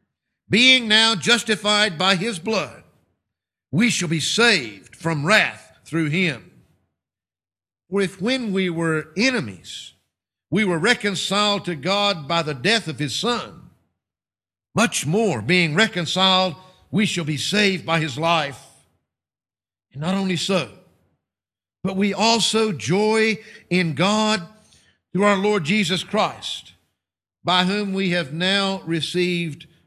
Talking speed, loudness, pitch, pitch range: 125 wpm, -20 LUFS, 180 Hz, 145-205 Hz